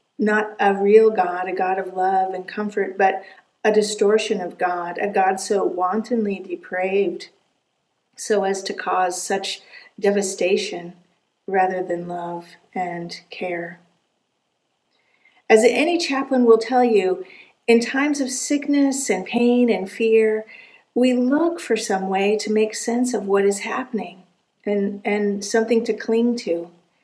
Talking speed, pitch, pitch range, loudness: 140 wpm, 205 Hz, 185-230 Hz, -20 LUFS